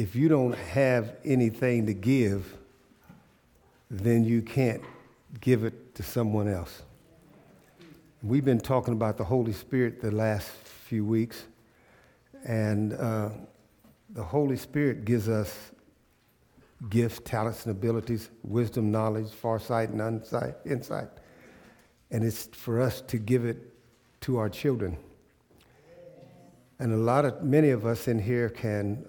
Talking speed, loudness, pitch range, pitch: 130 wpm, -28 LUFS, 110-130 Hz, 115 Hz